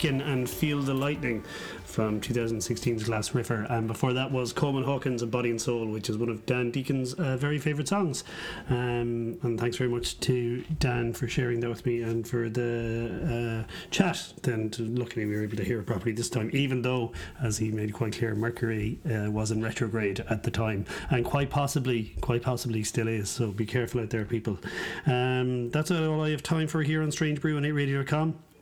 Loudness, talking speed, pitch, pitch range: -29 LUFS, 210 wpm, 120 Hz, 115-135 Hz